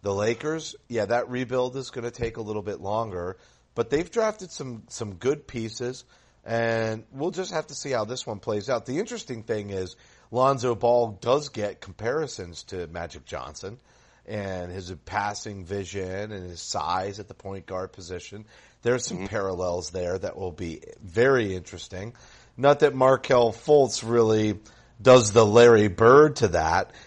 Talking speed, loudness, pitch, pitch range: 165 wpm, -24 LUFS, 115 Hz, 95-125 Hz